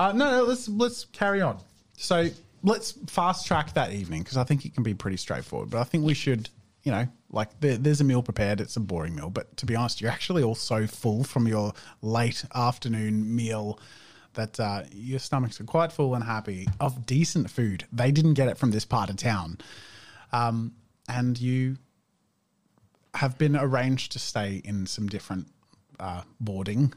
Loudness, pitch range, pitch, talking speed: -27 LUFS, 105-140 Hz, 120 Hz, 190 wpm